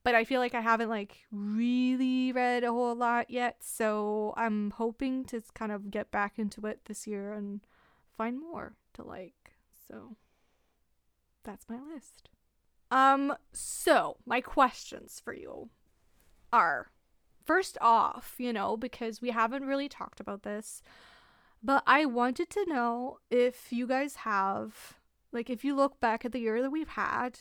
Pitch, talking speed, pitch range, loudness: 240 Hz, 160 wpm, 215-260 Hz, -31 LUFS